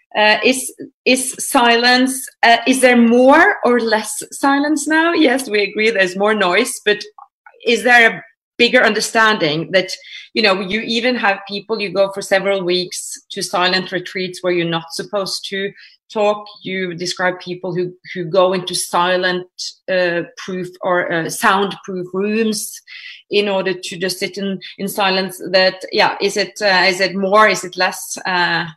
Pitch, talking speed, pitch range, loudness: 195 Hz, 165 wpm, 185-225 Hz, -15 LUFS